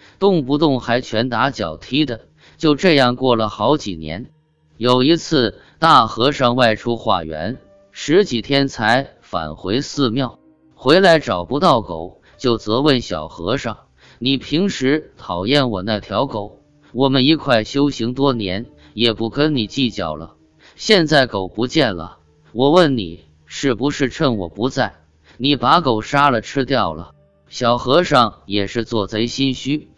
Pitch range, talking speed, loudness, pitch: 105-140 Hz, 210 characters per minute, -17 LUFS, 120 Hz